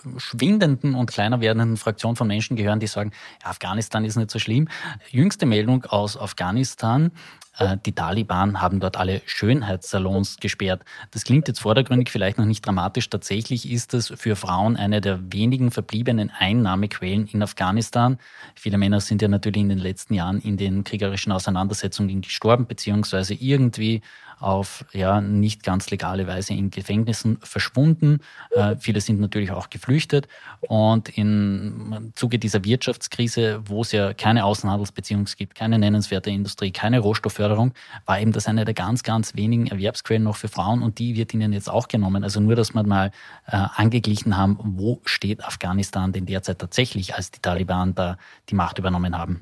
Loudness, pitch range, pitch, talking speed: -22 LUFS, 100-115 Hz, 105 Hz, 165 wpm